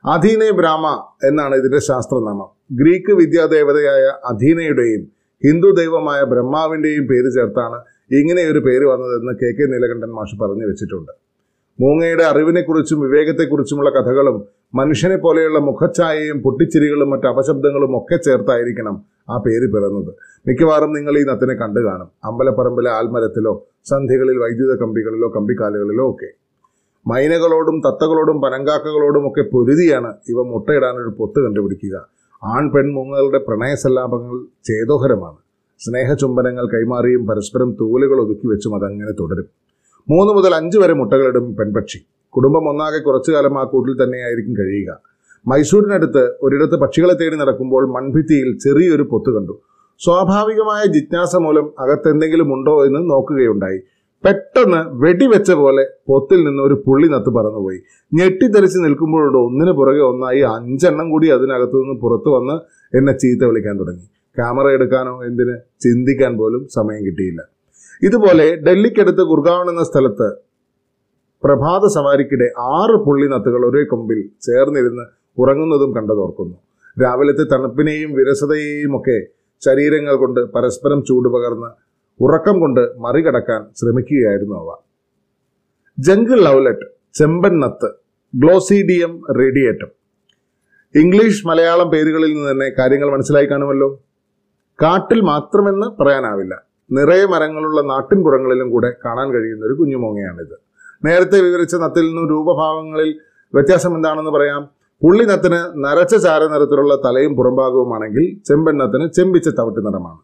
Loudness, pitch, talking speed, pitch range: -14 LUFS, 140 Hz, 110 wpm, 125-160 Hz